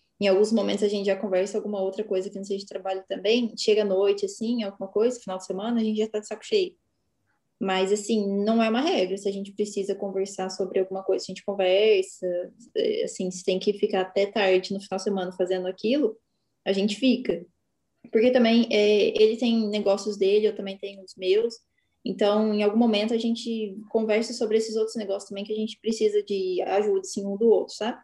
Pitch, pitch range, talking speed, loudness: 205 Hz, 195-220 Hz, 215 wpm, -25 LUFS